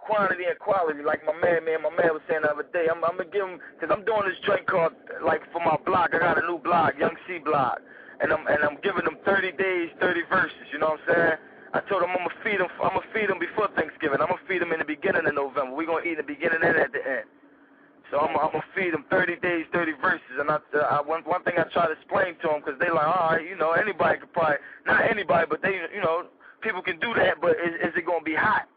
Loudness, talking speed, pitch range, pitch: -25 LUFS, 285 wpm, 155-185 Hz, 165 Hz